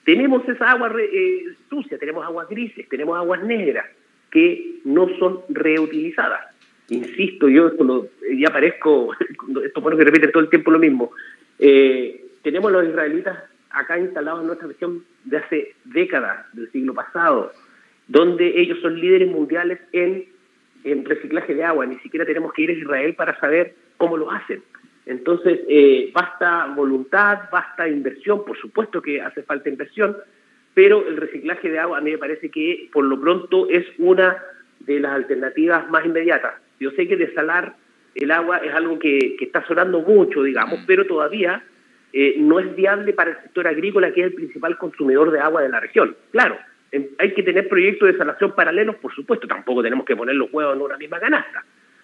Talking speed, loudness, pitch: 180 wpm, -19 LUFS, 185 Hz